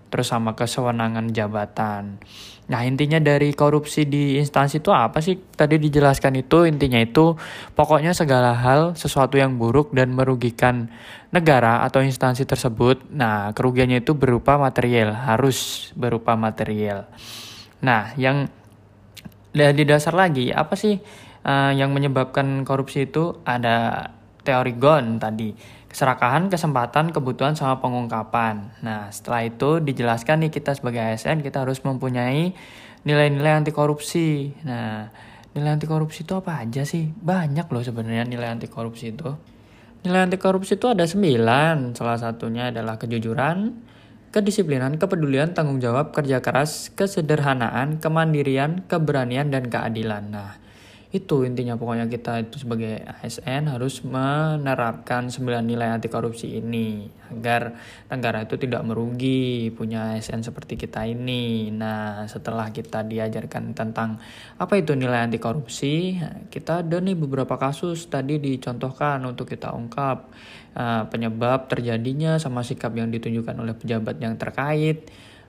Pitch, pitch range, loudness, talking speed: 130 Hz, 115-150 Hz, -22 LUFS, 130 wpm